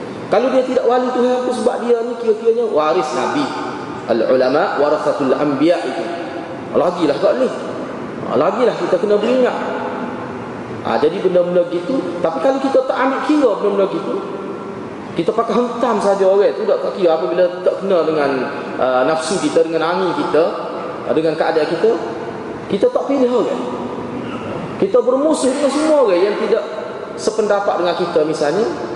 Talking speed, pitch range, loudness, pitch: 145 wpm, 190-275 Hz, -17 LUFS, 245 Hz